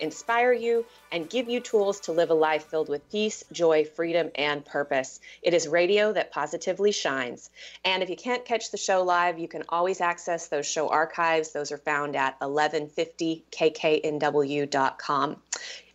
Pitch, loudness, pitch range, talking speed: 165 Hz, -26 LUFS, 150-190 Hz, 160 wpm